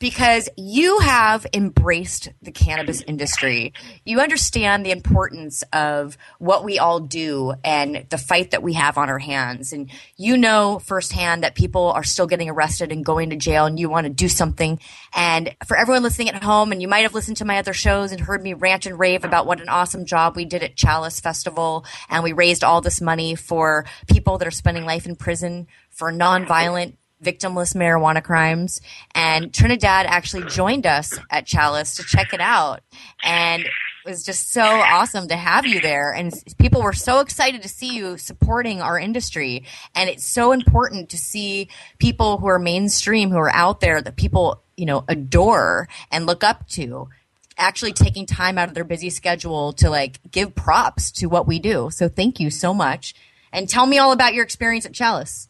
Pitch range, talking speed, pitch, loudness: 160-195 Hz, 195 wpm, 175 Hz, -19 LUFS